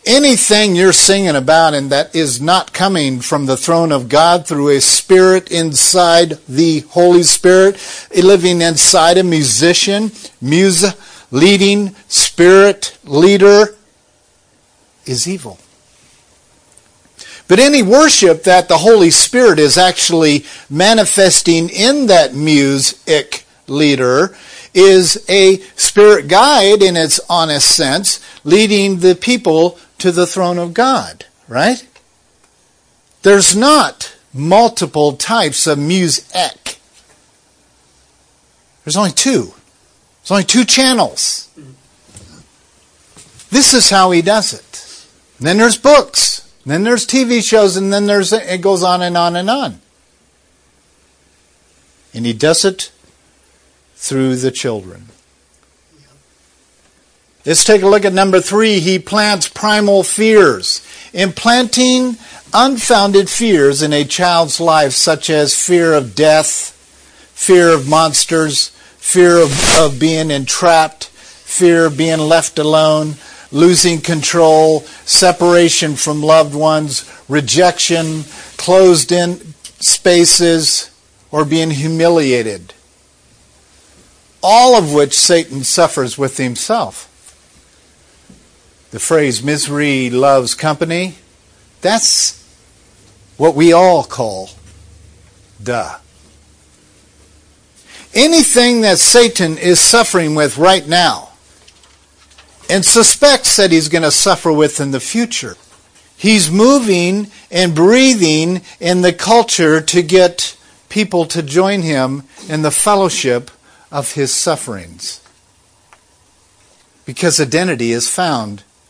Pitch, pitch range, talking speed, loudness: 165 Hz, 140-195 Hz, 110 wpm, -10 LUFS